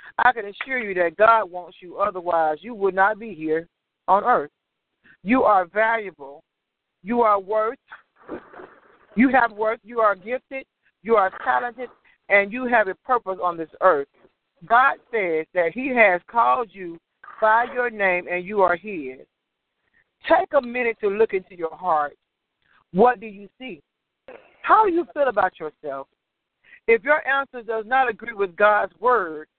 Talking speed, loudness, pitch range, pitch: 160 wpm, -21 LUFS, 180-245 Hz, 210 Hz